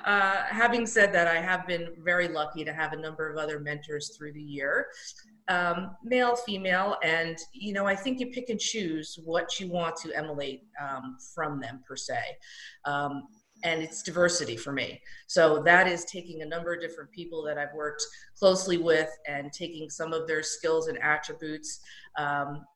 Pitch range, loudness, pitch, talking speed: 150-185 Hz, -28 LUFS, 165 Hz, 185 wpm